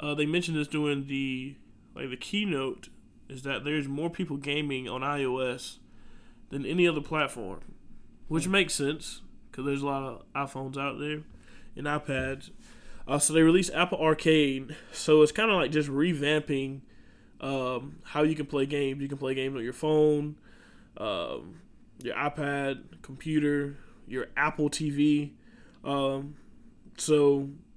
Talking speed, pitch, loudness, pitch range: 150 wpm, 145 Hz, -29 LUFS, 135-155 Hz